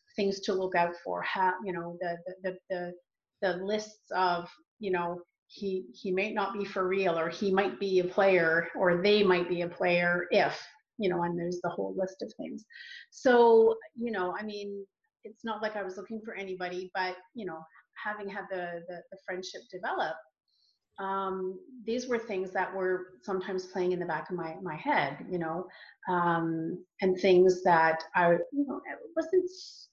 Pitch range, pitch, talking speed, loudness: 175-205 Hz, 185 Hz, 190 wpm, -30 LUFS